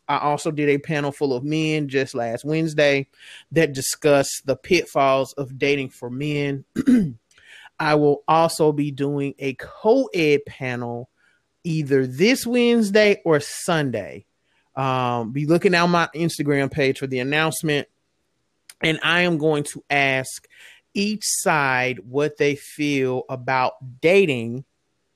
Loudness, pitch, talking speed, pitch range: -21 LUFS, 145 Hz, 130 wpm, 135-160 Hz